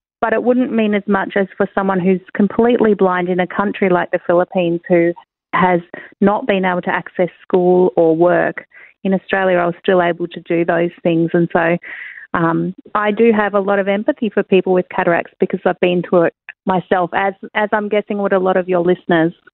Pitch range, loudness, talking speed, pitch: 175-200 Hz, -16 LUFS, 210 wpm, 185 Hz